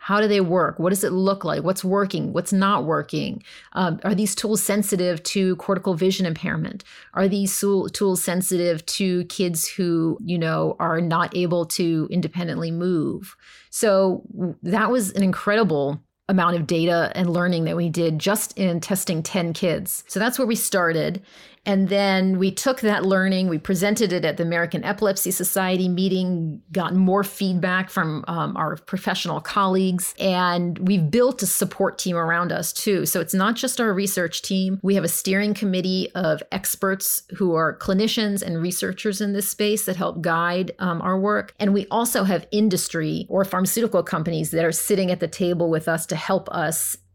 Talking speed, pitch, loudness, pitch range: 180 wpm, 185 Hz, -22 LUFS, 175-200 Hz